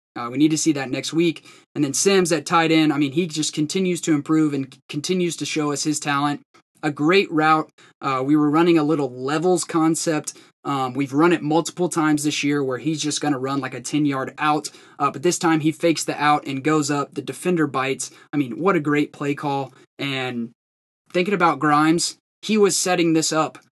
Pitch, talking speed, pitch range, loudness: 150 Hz, 225 wpm, 140-165 Hz, -21 LUFS